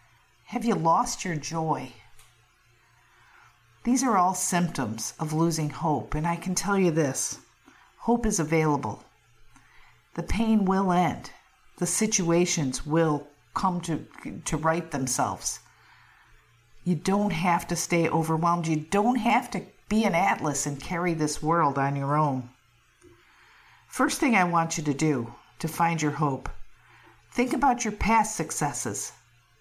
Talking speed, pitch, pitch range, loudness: 140 wpm, 165 Hz, 145-180 Hz, -26 LUFS